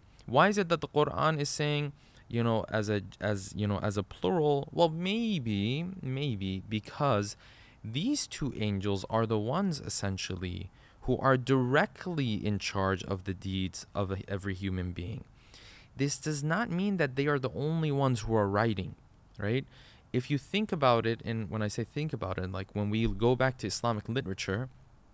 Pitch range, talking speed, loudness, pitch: 100-145 Hz, 180 wpm, -31 LUFS, 115 Hz